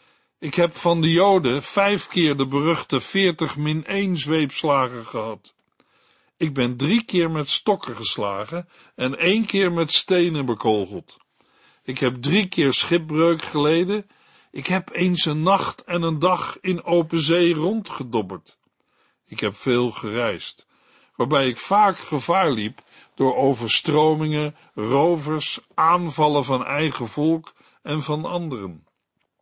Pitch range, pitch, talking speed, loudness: 135-175 Hz, 155 Hz, 130 wpm, -21 LUFS